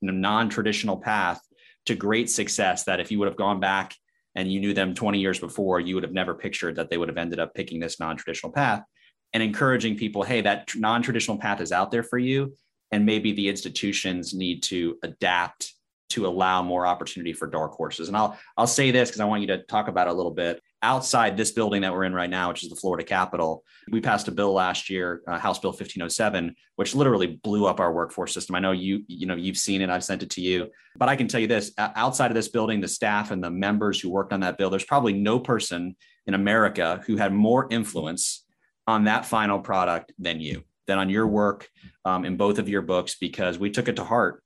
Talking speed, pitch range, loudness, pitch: 230 wpm, 90-110 Hz, -25 LUFS, 100 Hz